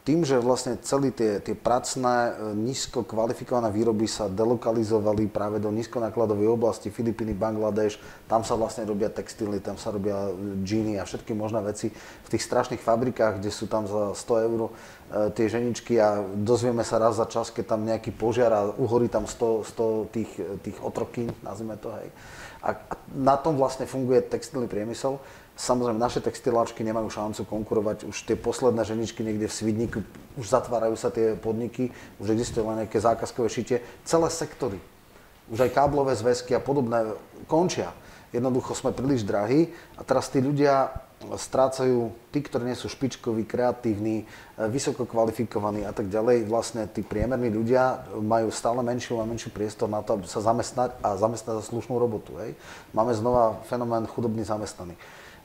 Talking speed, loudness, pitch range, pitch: 160 wpm, -27 LUFS, 110-125 Hz, 115 Hz